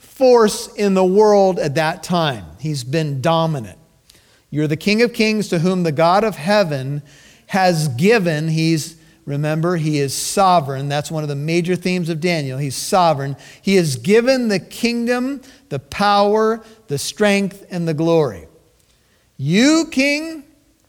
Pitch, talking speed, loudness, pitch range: 170 Hz, 150 wpm, -17 LUFS, 150-210 Hz